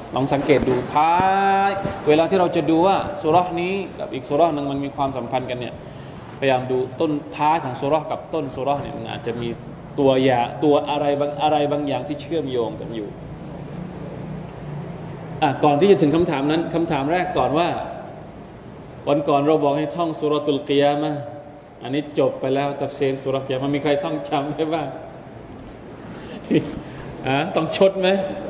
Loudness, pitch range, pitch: -21 LUFS, 140-165 Hz, 150 Hz